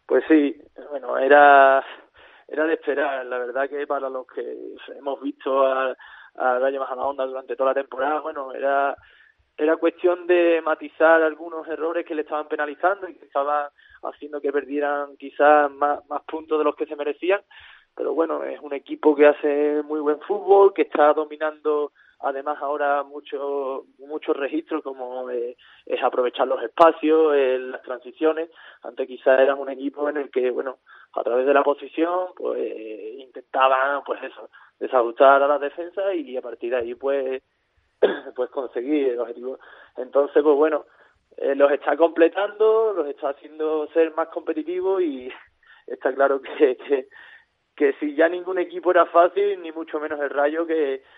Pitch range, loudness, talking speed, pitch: 140-175 Hz, -22 LUFS, 165 wpm, 150 Hz